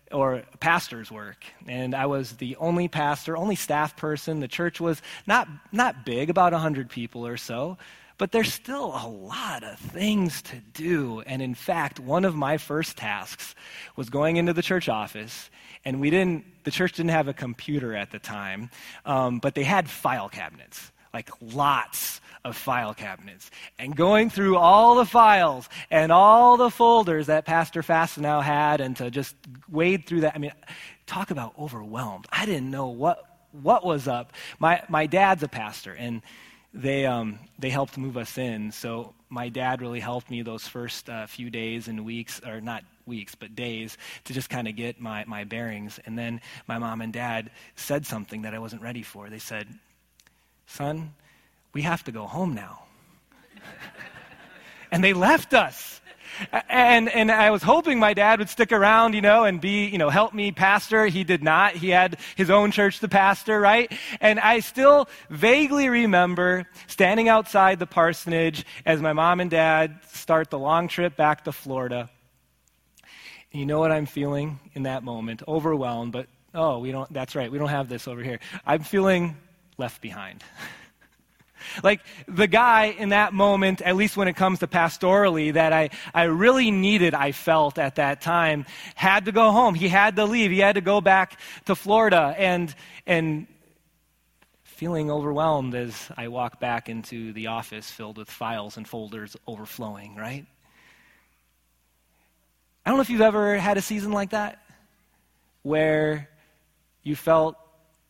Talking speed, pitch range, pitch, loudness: 175 wpm, 120-190 Hz, 155 Hz, -22 LUFS